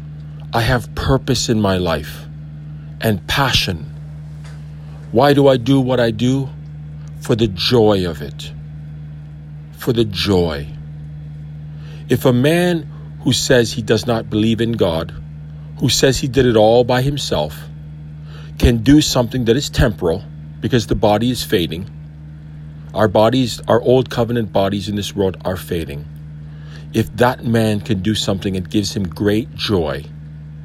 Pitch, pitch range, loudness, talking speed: 95 Hz, 75-120 Hz, -16 LUFS, 145 wpm